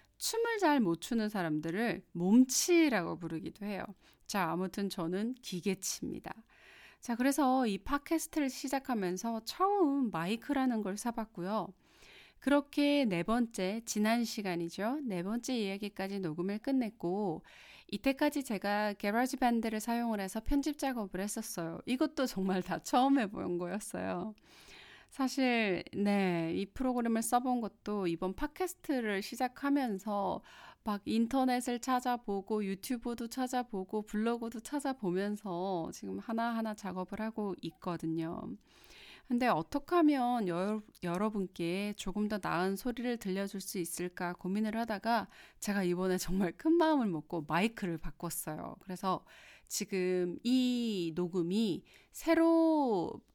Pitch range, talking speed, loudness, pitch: 185-250 Hz, 285 characters per minute, -34 LUFS, 215 Hz